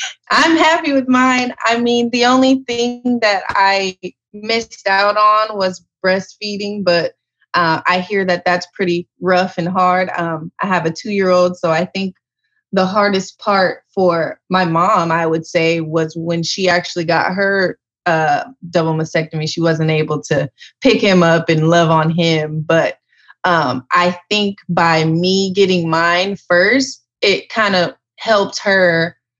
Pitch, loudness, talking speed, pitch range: 180 Hz, -15 LUFS, 160 wpm, 165-205 Hz